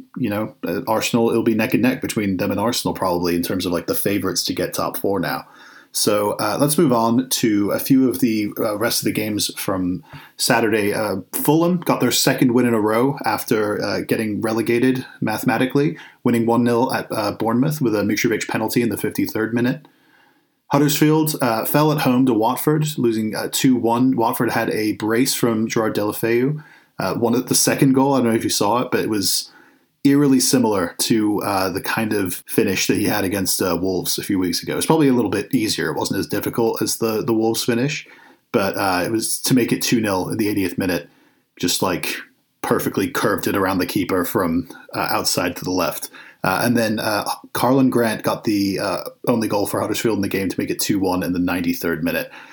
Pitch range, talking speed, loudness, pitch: 110-130 Hz, 215 wpm, -19 LUFS, 115 Hz